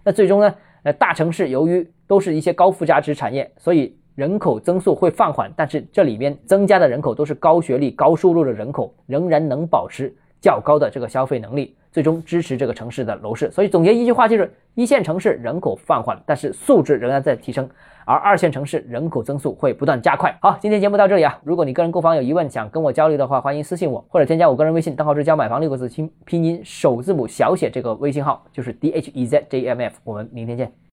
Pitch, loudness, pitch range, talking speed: 160 Hz, -18 LUFS, 140-175 Hz, 370 characters per minute